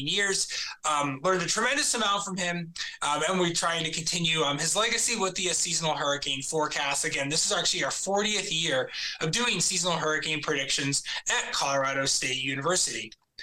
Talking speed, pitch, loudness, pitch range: 175 wpm, 165 Hz, -26 LUFS, 145-190 Hz